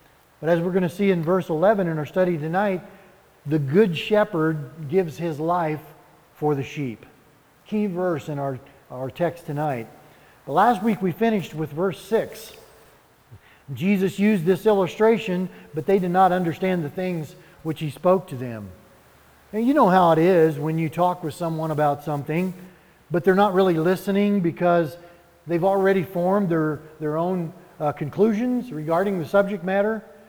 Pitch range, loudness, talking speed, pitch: 155-195 Hz, -22 LUFS, 165 wpm, 175 Hz